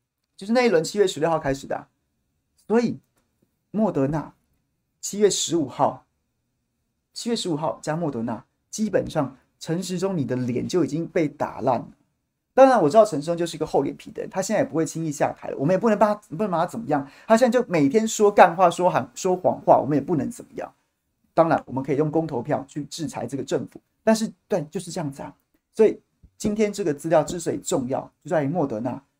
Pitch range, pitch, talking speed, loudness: 145-215 Hz, 170 Hz, 325 characters per minute, -23 LUFS